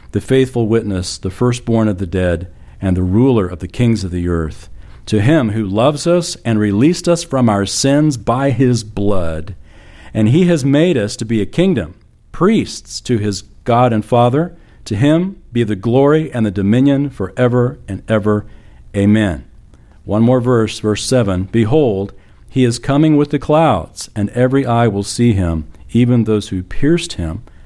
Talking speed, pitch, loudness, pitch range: 180 wpm, 110 Hz, -15 LUFS, 100-130 Hz